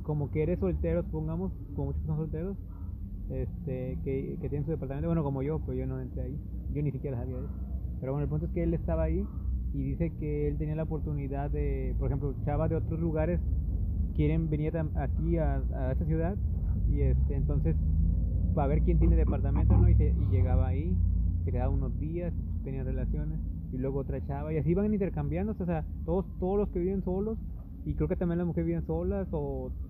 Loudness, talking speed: -31 LUFS, 205 wpm